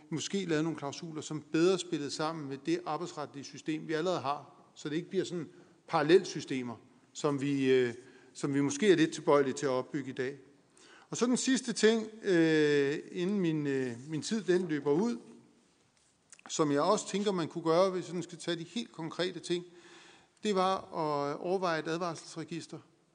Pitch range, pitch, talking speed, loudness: 145-175 Hz, 160 Hz, 175 wpm, -32 LUFS